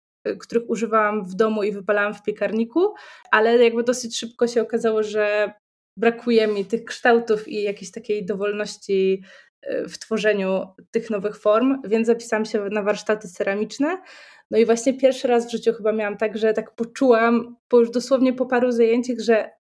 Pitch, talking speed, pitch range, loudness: 225 Hz, 165 wpm, 210-235 Hz, -21 LUFS